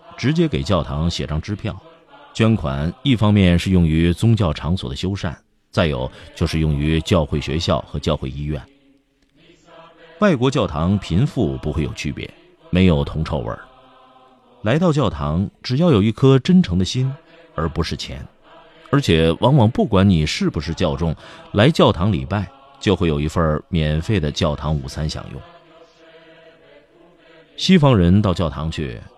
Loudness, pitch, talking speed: -19 LUFS, 100 Hz, 225 characters per minute